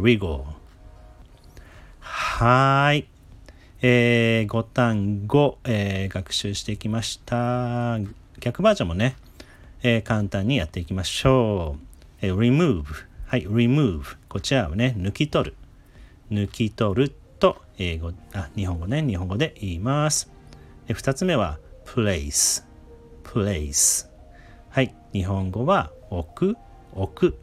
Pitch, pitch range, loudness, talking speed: 105 Hz, 90-125 Hz, -23 LUFS, 225 characters per minute